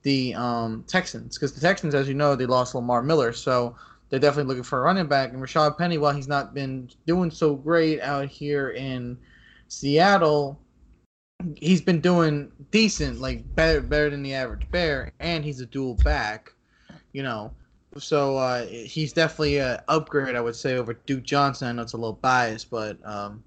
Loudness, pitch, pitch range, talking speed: -24 LUFS, 140 Hz, 125-155 Hz, 185 wpm